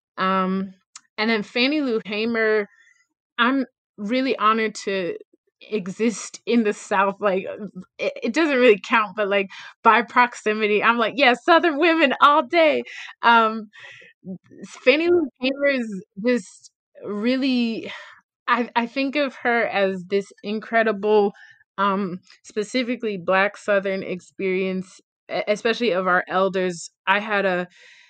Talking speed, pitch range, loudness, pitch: 125 wpm, 195-255 Hz, -21 LUFS, 220 Hz